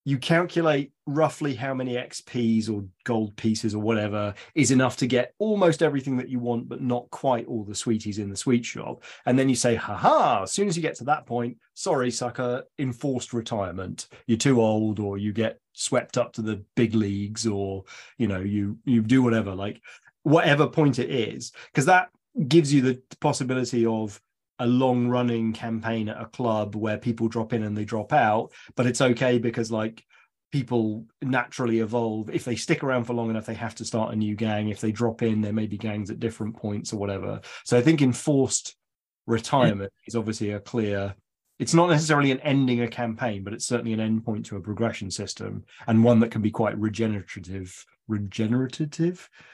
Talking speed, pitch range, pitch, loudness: 195 wpm, 110-130 Hz, 115 Hz, -25 LUFS